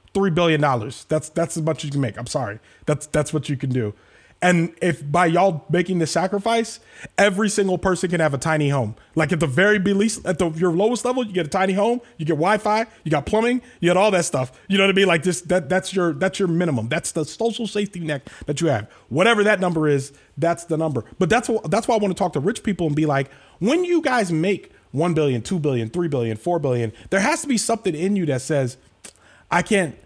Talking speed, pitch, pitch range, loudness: 250 wpm, 175 Hz, 150-200 Hz, -21 LUFS